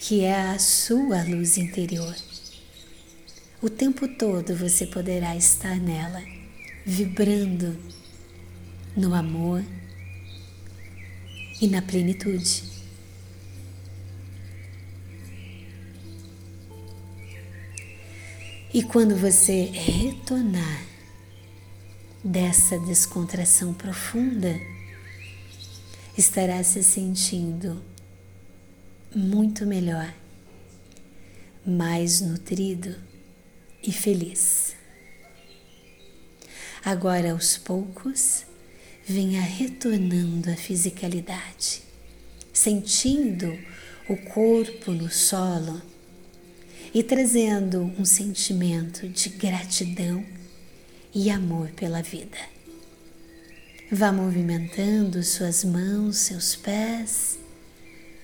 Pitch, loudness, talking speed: 175 Hz, -23 LUFS, 65 wpm